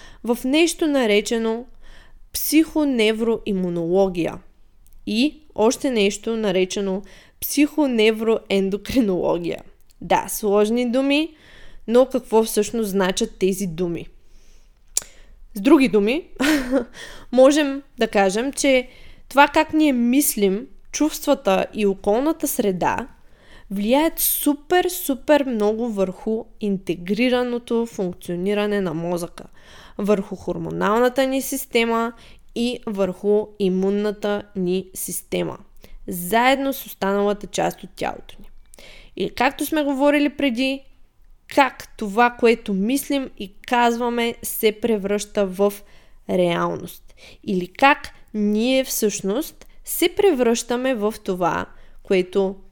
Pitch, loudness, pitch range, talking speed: 225 Hz, -21 LUFS, 200-270 Hz, 95 wpm